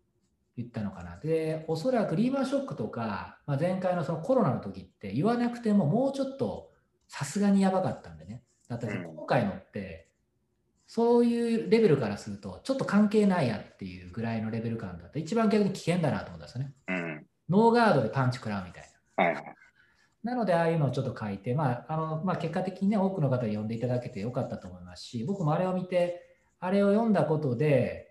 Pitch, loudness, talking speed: 155 Hz, -29 LUFS, 435 characters per minute